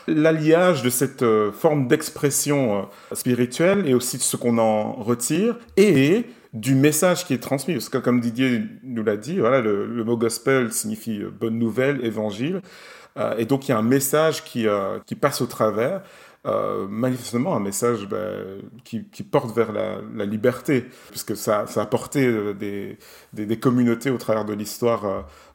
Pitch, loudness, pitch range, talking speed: 125 Hz, -22 LUFS, 110-145 Hz, 185 wpm